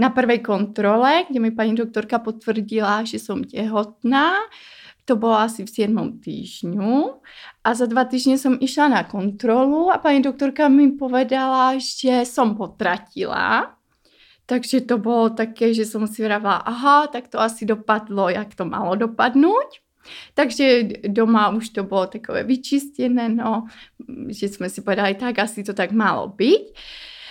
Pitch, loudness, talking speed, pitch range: 230 Hz, -20 LUFS, 150 wpm, 215-265 Hz